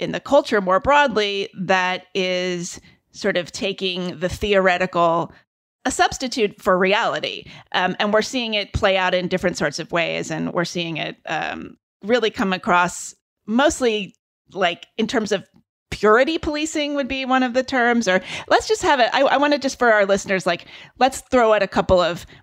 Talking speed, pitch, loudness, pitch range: 185 wpm, 205 Hz, -20 LUFS, 185-255 Hz